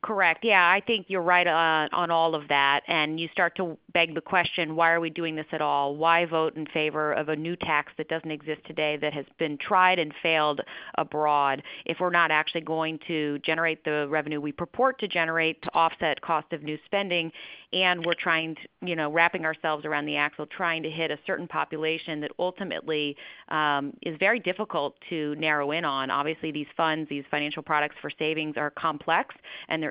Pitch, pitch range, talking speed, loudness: 160 Hz, 150-170 Hz, 205 wpm, -26 LUFS